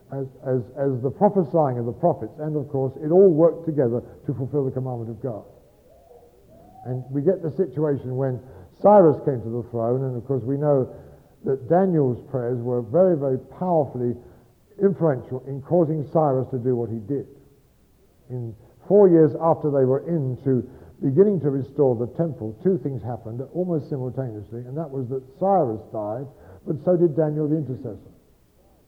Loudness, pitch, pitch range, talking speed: -23 LUFS, 135 Hz, 125-160 Hz, 170 wpm